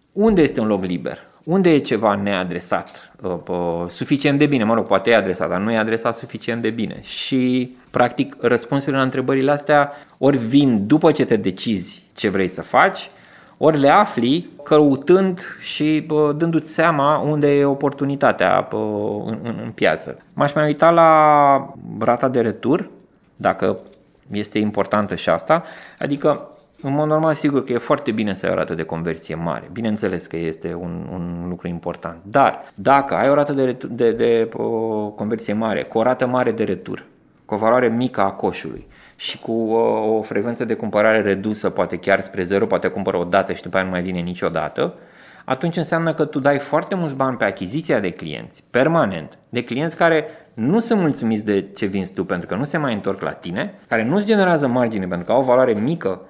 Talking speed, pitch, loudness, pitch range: 185 wpm, 125 Hz, -19 LUFS, 105-150 Hz